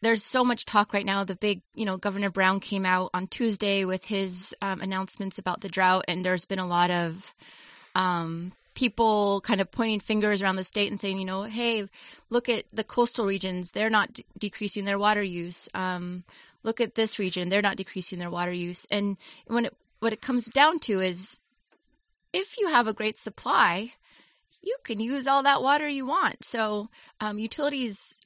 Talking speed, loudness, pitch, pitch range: 195 wpm, -27 LUFS, 205 Hz, 190-230 Hz